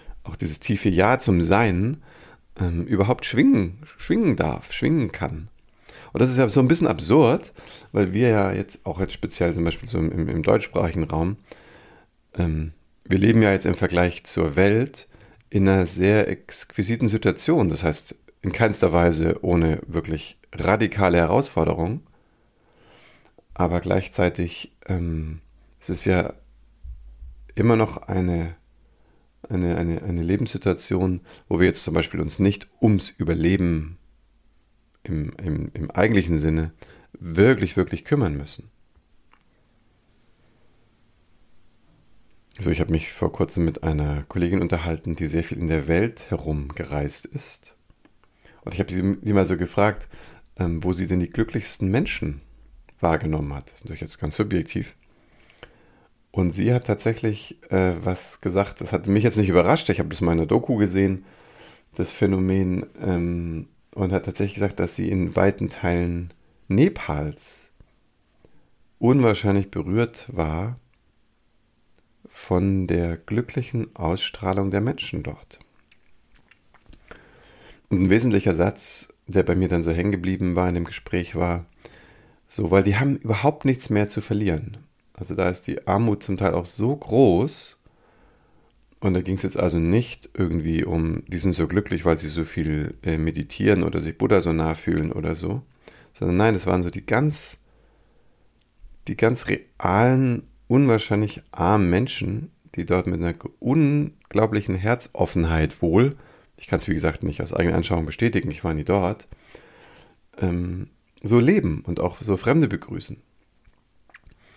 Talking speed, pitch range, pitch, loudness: 145 wpm, 85-110 Hz, 95 Hz, -23 LUFS